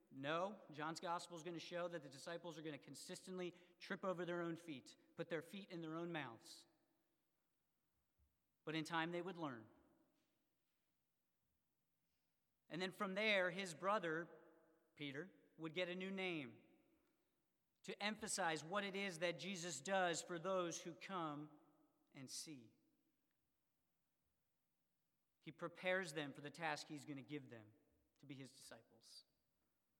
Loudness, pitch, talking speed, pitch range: -47 LUFS, 170 Hz, 145 wpm, 155-185 Hz